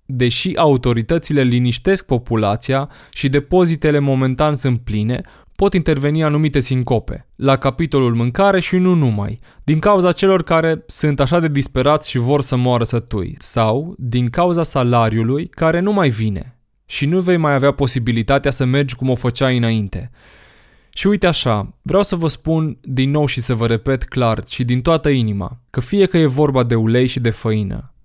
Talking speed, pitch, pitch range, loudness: 170 wpm, 135 Hz, 120-155 Hz, -16 LUFS